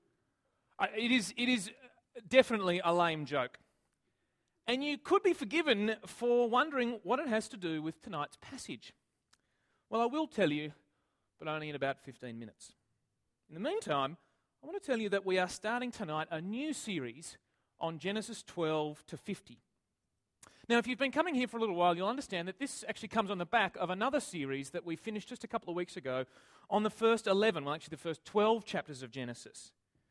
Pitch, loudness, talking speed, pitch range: 195 Hz, -34 LUFS, 195 wpm, 155-235 Hz